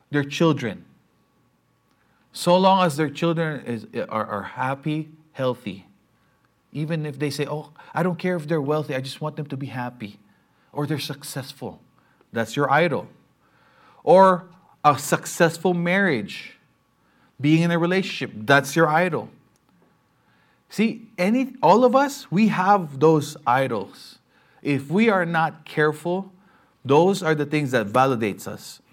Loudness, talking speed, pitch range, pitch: -22 LUFS, 140 wpm, 140-180 Hz, 155 Hz